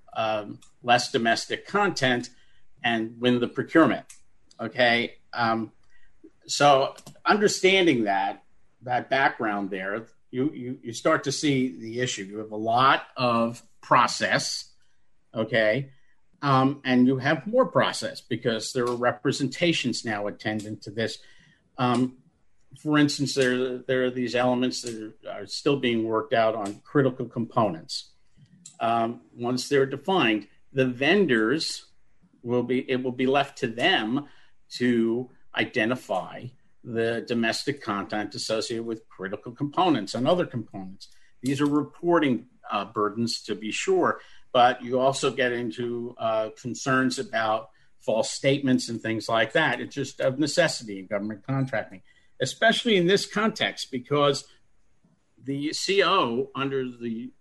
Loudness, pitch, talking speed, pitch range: -25 LUFS, 125 Hz, 135 wpm, 115-140 Hz